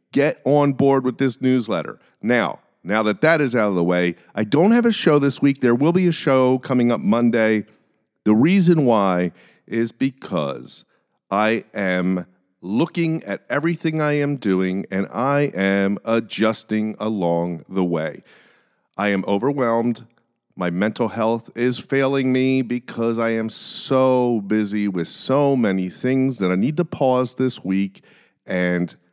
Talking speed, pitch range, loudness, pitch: 155 wpm, 100-135 Hz, -20 LUFS, 115 Hz